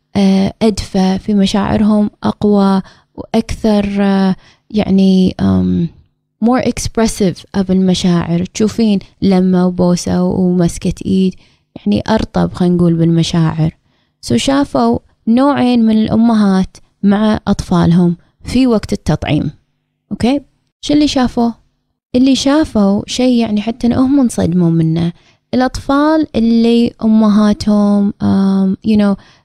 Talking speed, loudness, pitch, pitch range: 100 wpm, -13 LUFS, 205 Hz, 180-230 Hz